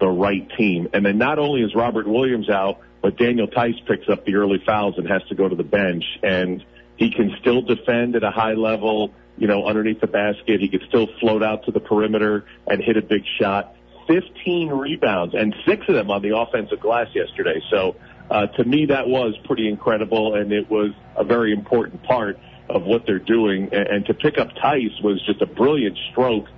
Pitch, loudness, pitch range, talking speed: 110 Hz, -20 LUFS, 100-120 Hz, 210 wpm